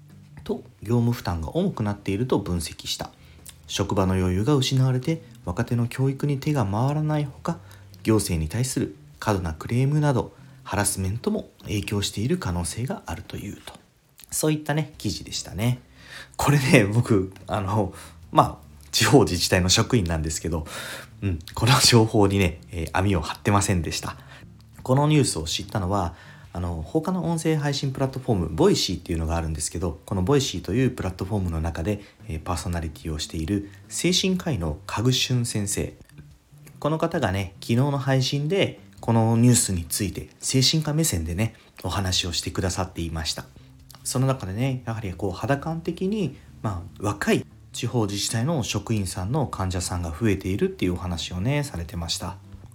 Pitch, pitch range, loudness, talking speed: 105 Hz, 90-130 Hz, -24 LUFS, 360 characters per minute